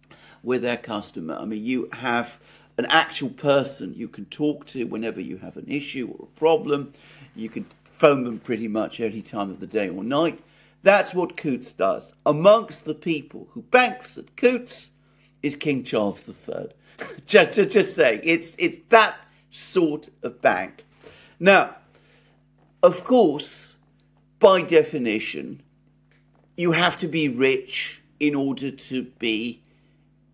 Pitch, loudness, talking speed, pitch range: 140 Hz, -22 LUFS, 145 wpm, 115-165 Hz